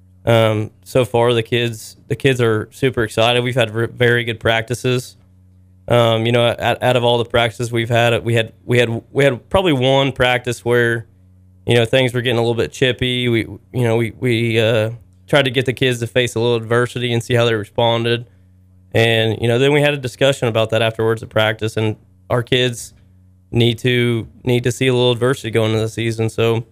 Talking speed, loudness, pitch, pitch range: 215 wpm, -17 LUFS, 115 Hz, 110-125 Hz